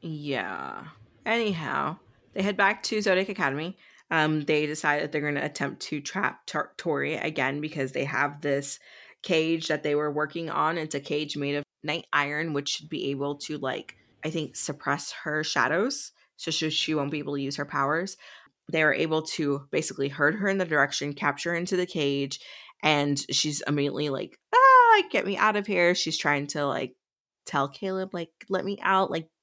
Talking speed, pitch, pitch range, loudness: 195 wpm, 150 Hz, 145-175 Hz, -26 LUFS